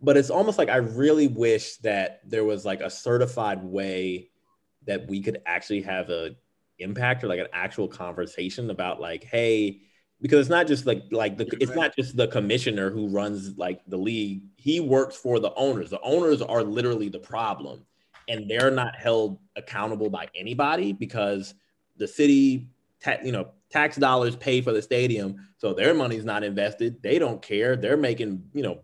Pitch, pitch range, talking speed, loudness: 110 Hz, 100-130 Hz, 185 wpm, -25 LUFS